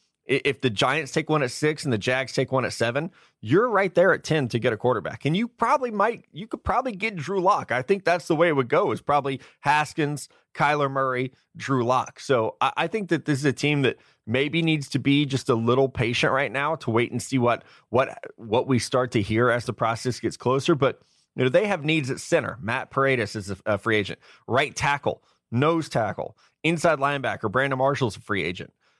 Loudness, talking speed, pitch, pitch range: -24 LUFS, 230 wpm, 135 Hz, 125-155 Hz